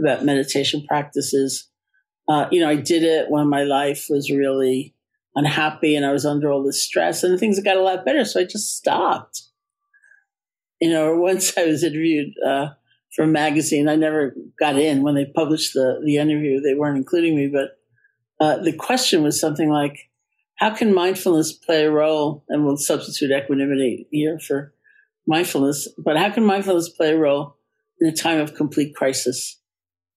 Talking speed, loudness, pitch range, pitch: 175 wpm, -20 LUFS, 140-170 Hz, 150 Hz